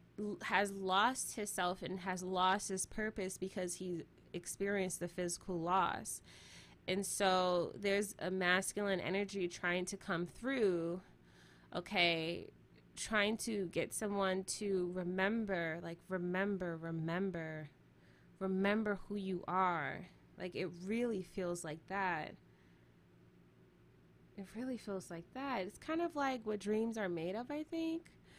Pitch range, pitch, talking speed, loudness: 175-205 Hz, 185 Hz, 125 wpm, -38 LUFS